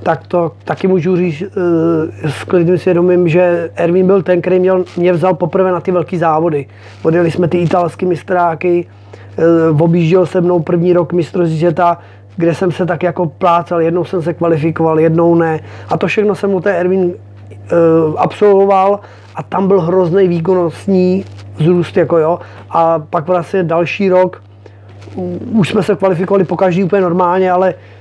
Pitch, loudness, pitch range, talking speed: 175 Hz, -13 LUFS, 165-185 Hz, 155 wpm